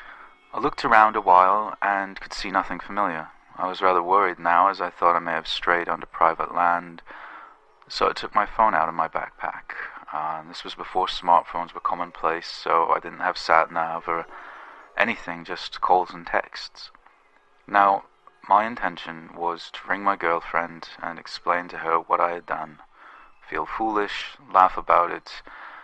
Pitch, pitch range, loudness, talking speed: 90 Hz, 85-100 Hz, -23 LUFS, 170 wpm